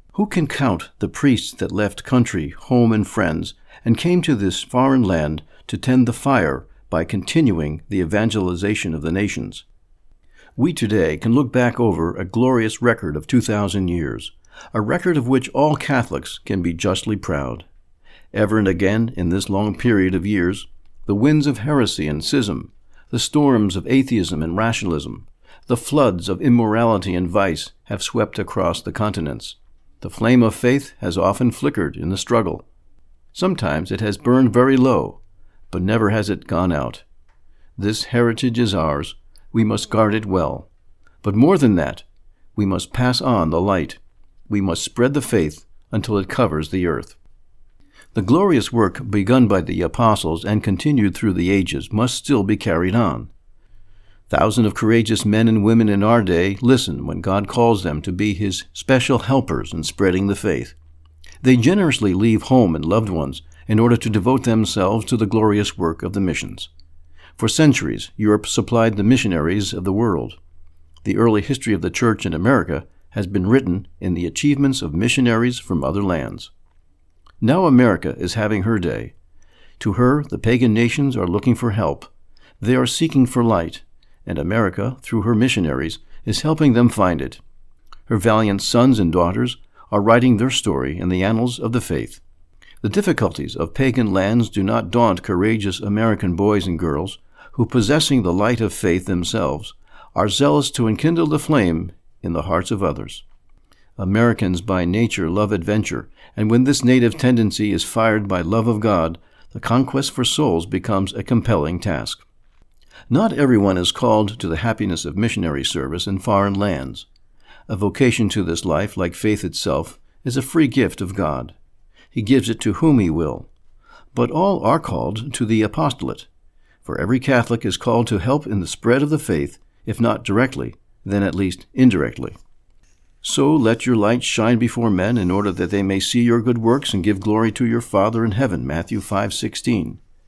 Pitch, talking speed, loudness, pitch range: 105 Hz, 175 wpm, -19 LUFS, 90-120 Hz